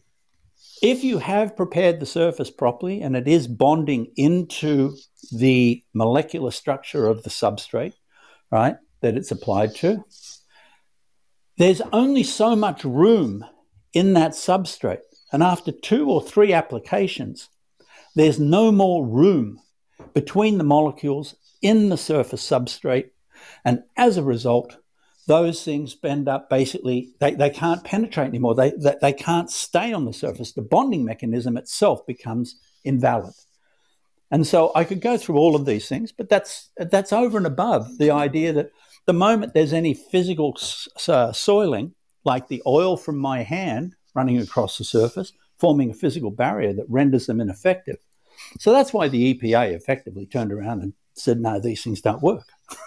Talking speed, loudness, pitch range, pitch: 150 wpm, -21 LUFS, 125-180 Hz, 150 Hz